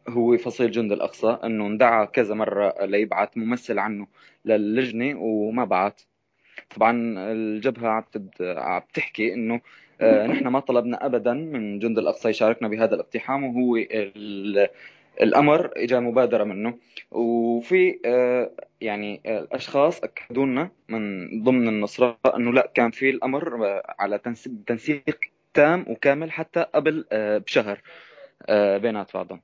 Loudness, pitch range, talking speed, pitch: -23 LUFS, 105-125 Hz, 120 wpm, 115 Hz